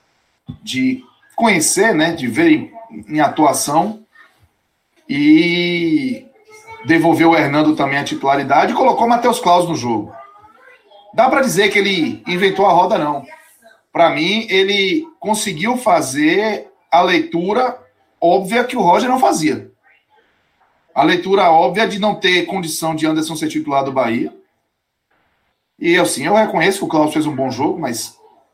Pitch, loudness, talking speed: 205 Hz, -15 LUFS, 145 wpm